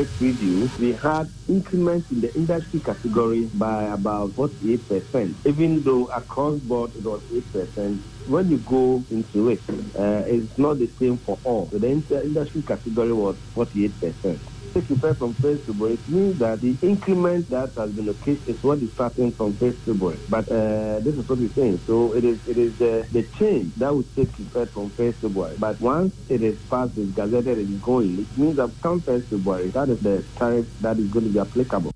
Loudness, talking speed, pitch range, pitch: -23 LUFS, 205 wpm, 110-135 Hz, 120 Hz